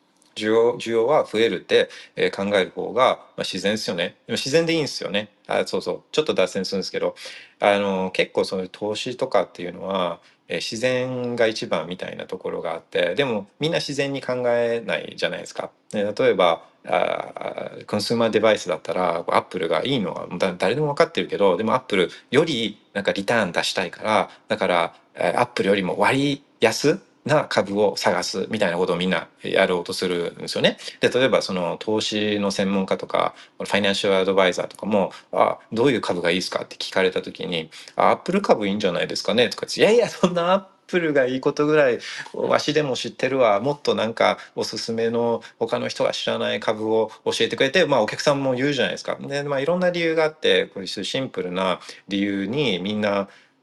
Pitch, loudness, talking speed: 130 Hz, -22 LUFS, 415 characters per minute